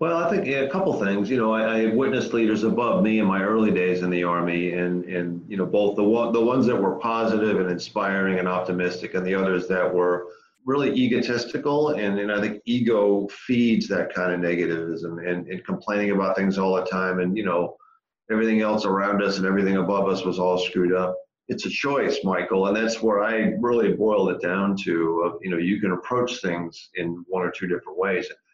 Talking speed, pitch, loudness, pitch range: 220 wpm, 100 Hz, -23 LUFS, 90-115 Hz